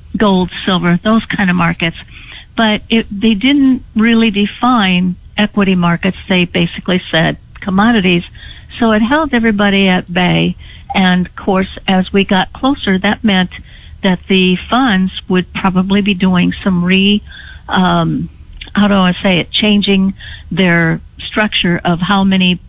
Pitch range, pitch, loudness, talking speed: 180-210 Hz, 190 Hz, -12 LUFS, 145 wpm